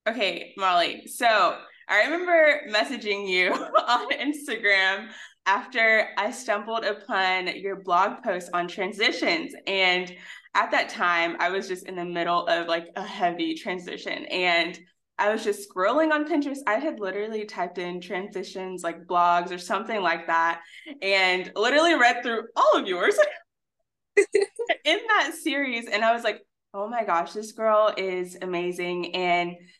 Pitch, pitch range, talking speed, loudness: 200 Hz, 180-245 Hz, 150 wpm, -24 LUFS